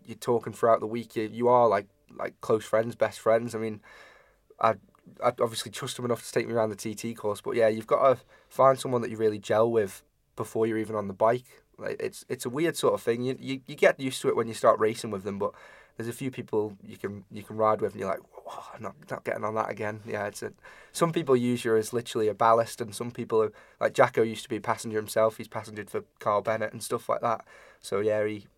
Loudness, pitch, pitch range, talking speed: -28 LUFS, 115 Hz, 110-120 Hz, 260 wpm